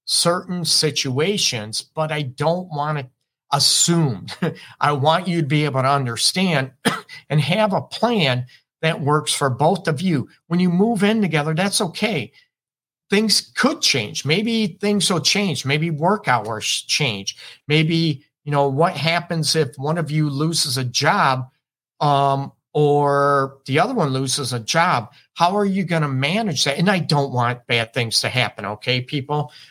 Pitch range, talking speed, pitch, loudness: 135-175 Hz, 165 wpm, 150 Hz, -19 LUFS